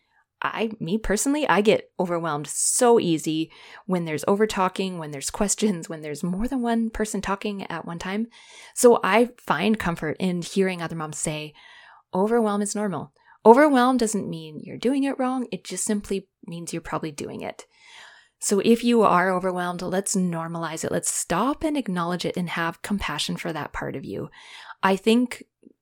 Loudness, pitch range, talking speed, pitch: -24 LUFS, 170-230 Hz, 175 wpm, 195 Hz